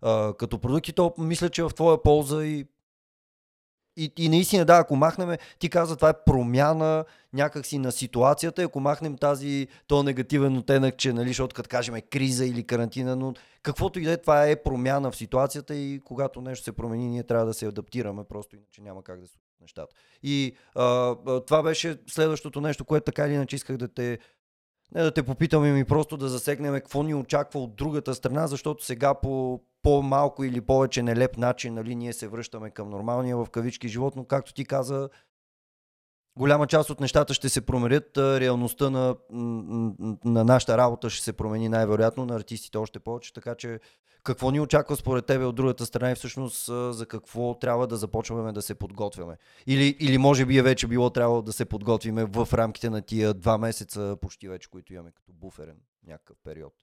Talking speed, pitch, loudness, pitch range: 190 wpm, 130 Hz, -25 LUFS, 115-145 Hz